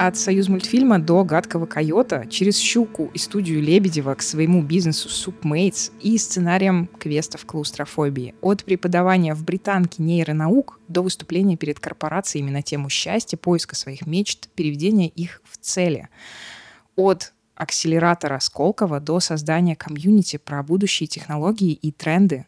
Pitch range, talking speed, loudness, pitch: 155-190 Hz, 130 wpm, -21 LUFS, 170 Hz